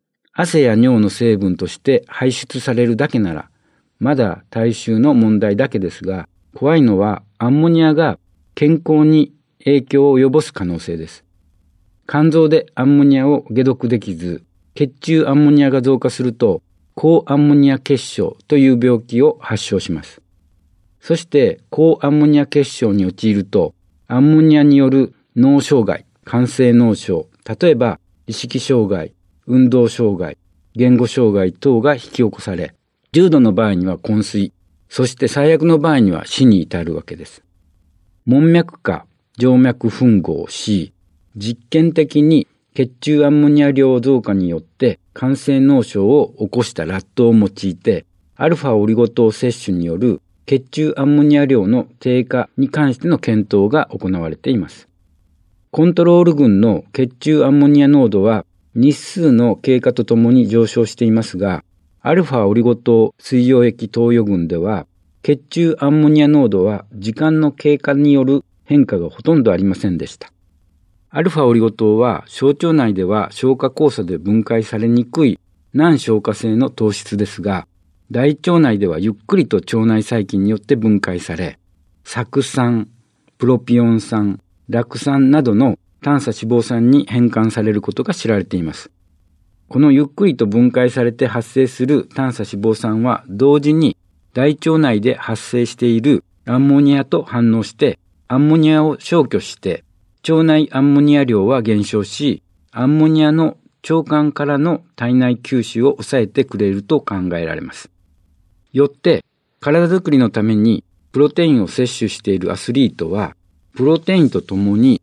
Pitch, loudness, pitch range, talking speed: 120 Hz, -15 LUFS, 100-140 Hz, 300 characters per minute